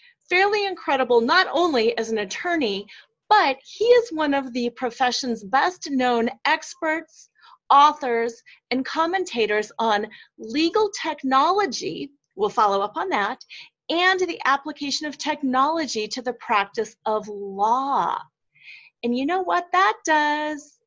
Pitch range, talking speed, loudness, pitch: 235-350 Hz, 125 wpm, -22 LUFS, 275 Hz